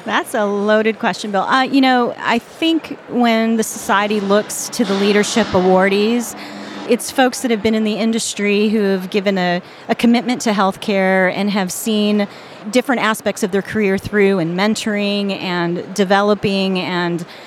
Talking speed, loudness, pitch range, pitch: 165 wpm, -16 LUFS, 195-230 Hz, 210 Hz